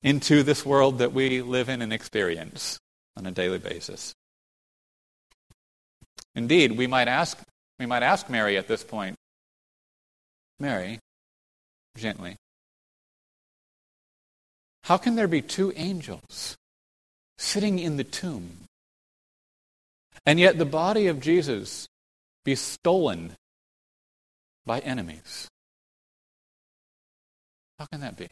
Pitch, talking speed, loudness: 135 Hz, 105 wpm, -25 LUFS